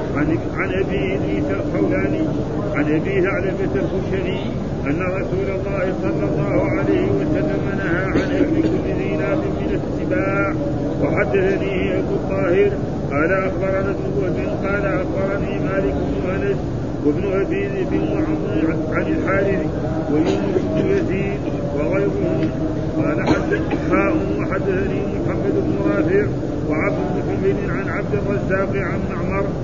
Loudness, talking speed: -20 LUFS, 110 wpm